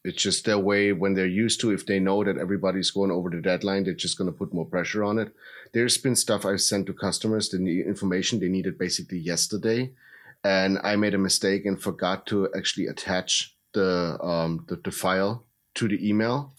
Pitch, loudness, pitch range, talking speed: 100 Hz, -25 LUFS, 95-105 Hz, 205 wpm